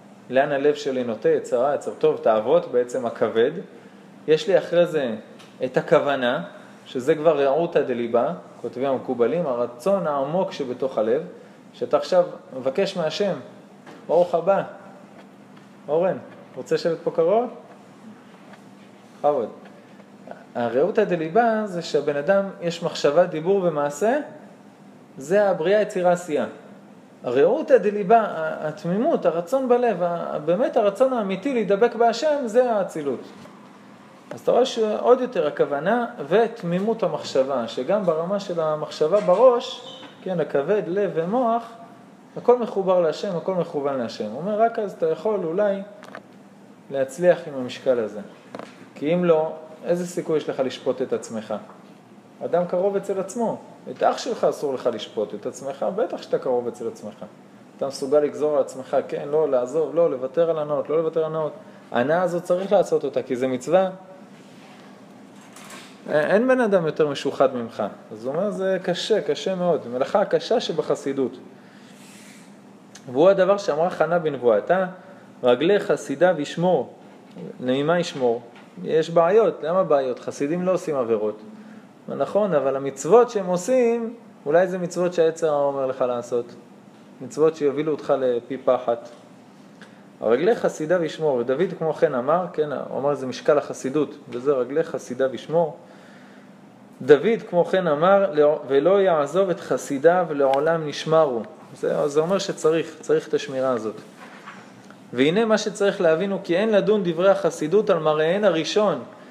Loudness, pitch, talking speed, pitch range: -22 LUFS, 180 Hz, 140 wpm, 155-220 Hz